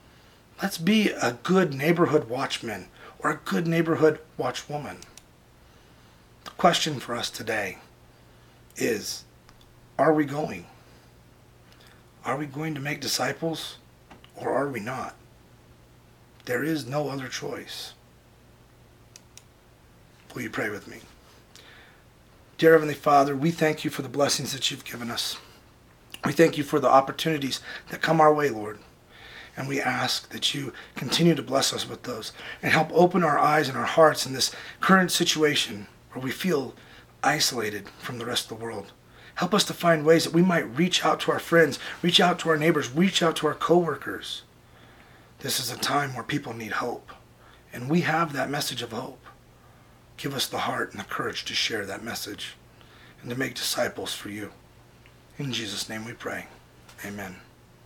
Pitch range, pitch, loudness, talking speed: 100-160 Hz, 145 Hz, -25 LUFS, 165 wpm